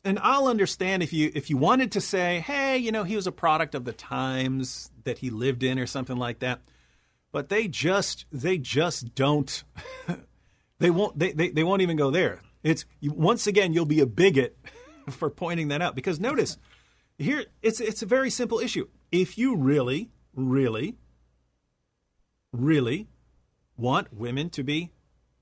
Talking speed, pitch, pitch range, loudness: 170 wpm, 155 Hz, 130-190 Hz, -26 LUFS